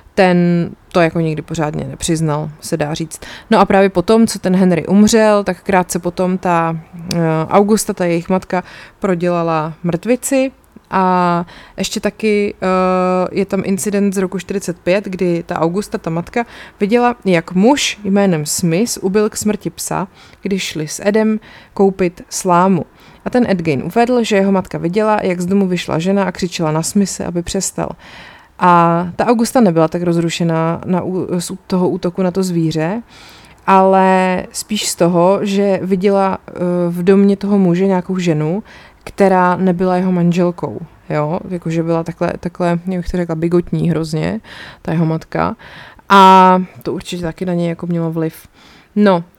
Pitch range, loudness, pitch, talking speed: 170-195 Hz, -15 LUFS, 185 Hz, 155 wpm